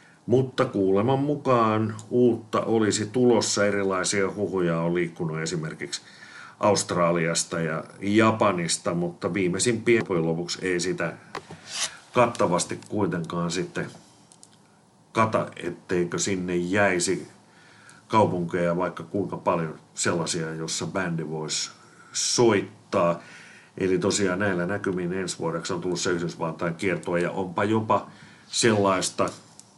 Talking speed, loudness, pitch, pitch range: 105 wpm, -25 LUFS, 95 Hz, 85-110 Hz